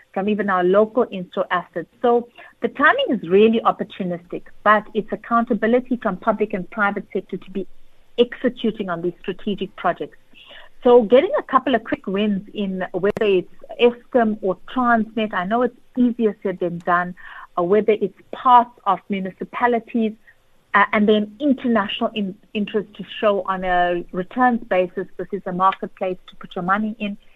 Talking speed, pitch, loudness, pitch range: 160 wpm, 210 Hz, -20 LUFS, 190-235 Hz